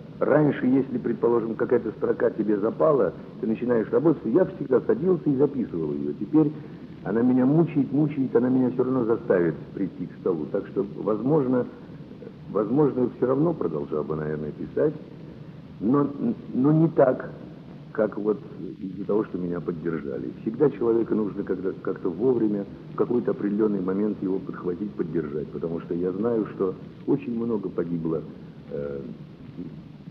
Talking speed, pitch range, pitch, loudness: 145 wpm, 90-145 Hz, 110 Hz, -25 LUFS